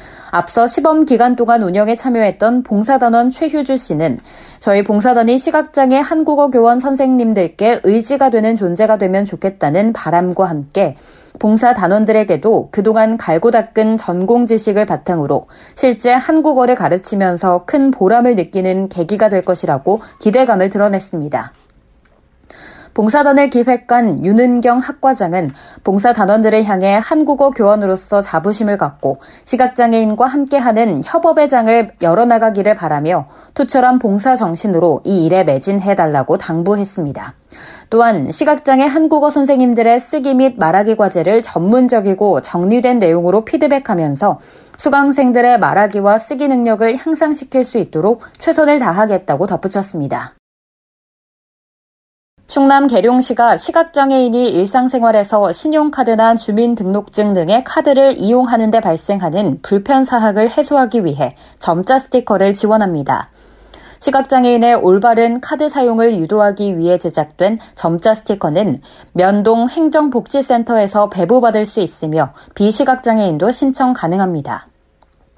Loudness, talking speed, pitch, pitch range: -13 LUFS, 325 characters per minute, 225 Hz, 190-255 Hz